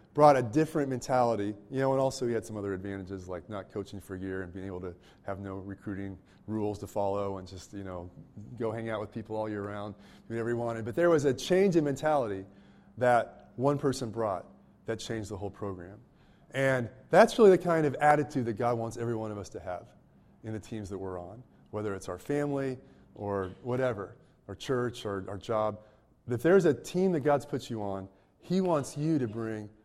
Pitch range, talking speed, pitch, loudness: 100-135 Hz, 220 wpm, 110 Hz, -30 LUFS